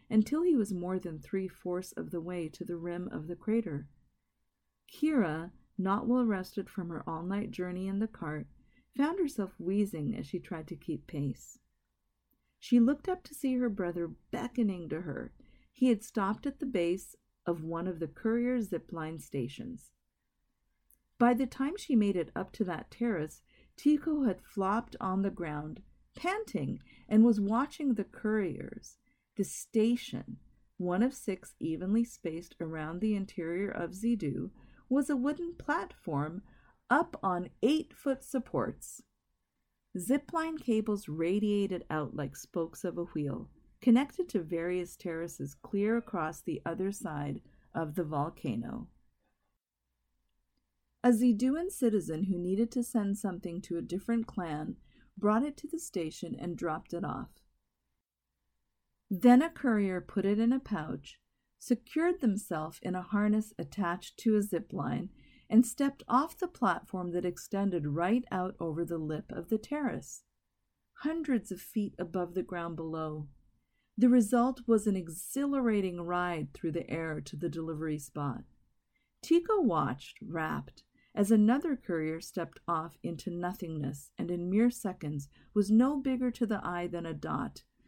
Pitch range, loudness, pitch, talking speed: 170-240 Hz, -33 LUFS, 195 Hz, 150 wpm